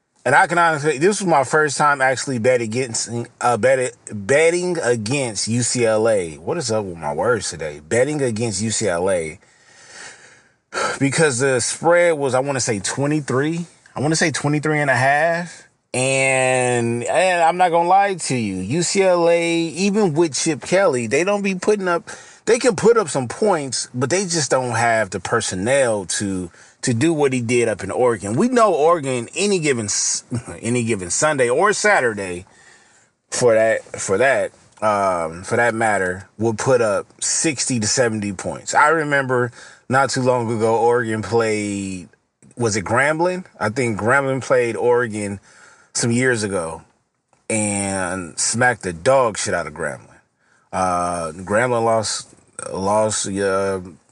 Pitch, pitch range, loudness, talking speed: 125 Hz, 110-160 Hz, -19 LUFS, 155 wpm